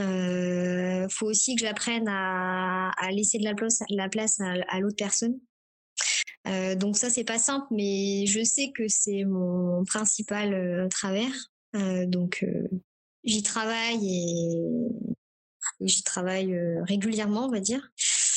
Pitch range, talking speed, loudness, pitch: 185-225 Hz, 145 wpm, -27 LUFS, 200 Hz